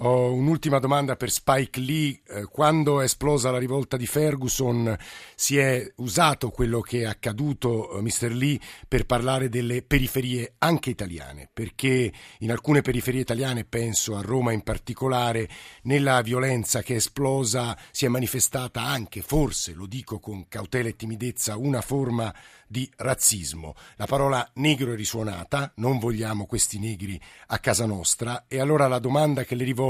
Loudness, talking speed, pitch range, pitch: -25 LUFS, 160 wpm, 115-135 Hz, 125 Hz